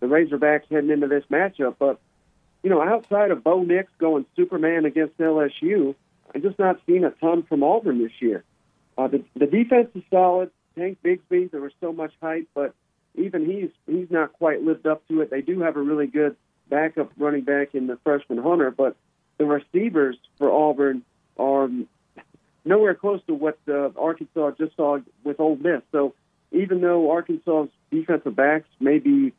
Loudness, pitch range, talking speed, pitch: -22 LUFS, 145-175 Hz, 180 wpm, 155 Hz